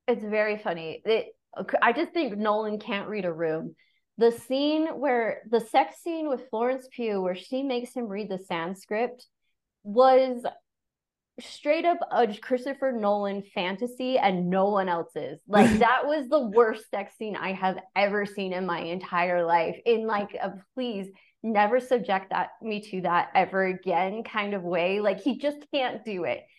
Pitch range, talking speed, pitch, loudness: 190-255 Hz, 170 wpm, 215 Hz, -27 LUFS